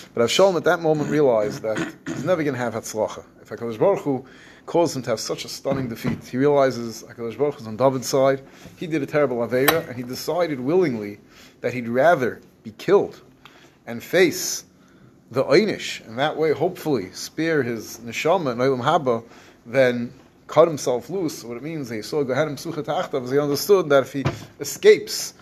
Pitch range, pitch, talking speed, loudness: 120-150 Hz, 135 Hz, 170 wpm, -22 LUFS